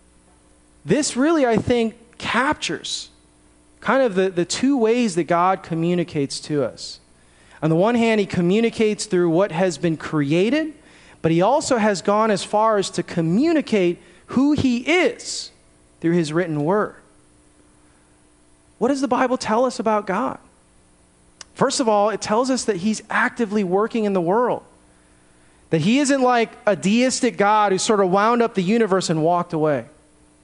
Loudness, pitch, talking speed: -20 LUFS, 190 Hz, 160 wpm